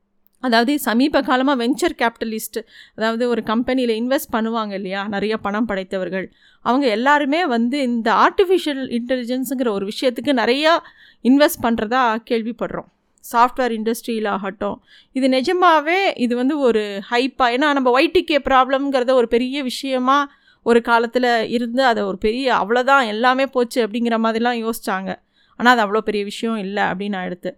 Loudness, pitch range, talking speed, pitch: -18 LUFS, 220-270 Hz, 135 wpm, 240 Hz